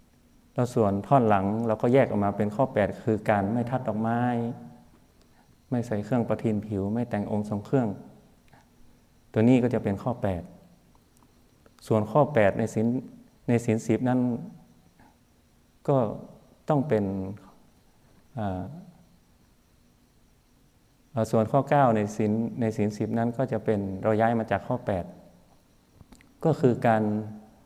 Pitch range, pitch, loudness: 105-120 Hz, 110 Hz, -26 LUFS